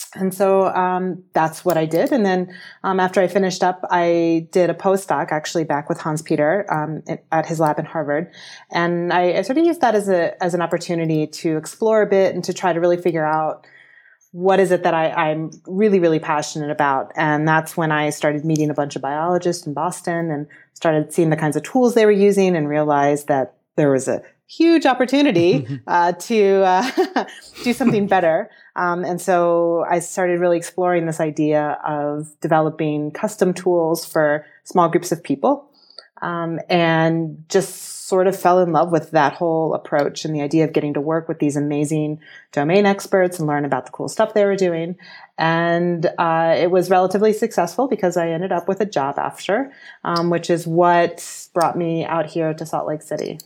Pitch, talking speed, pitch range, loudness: 170 Hz, 195 wpm, 155-185 Hz, -19 LUFS